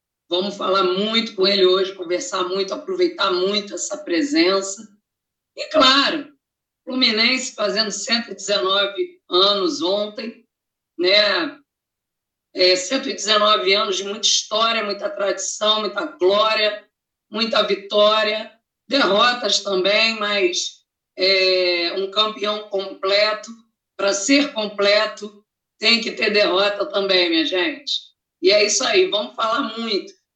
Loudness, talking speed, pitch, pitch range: -18 LUFS, 110 wpm, 210 Hz, 195-245 Hz